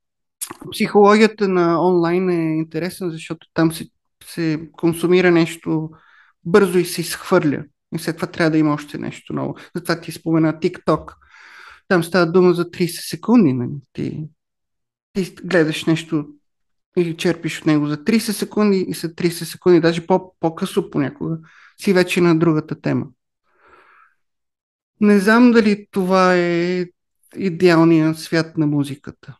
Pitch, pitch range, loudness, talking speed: 170 Hz, 160-185 Hz, -18 LUFS, 135 wpm